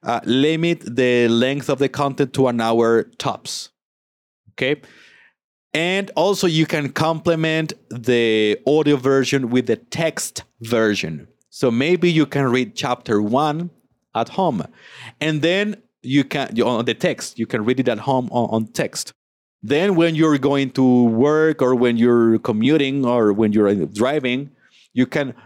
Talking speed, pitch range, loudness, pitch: 155 wpm, 120-155 Hz, -19 LUFS, 130 Hz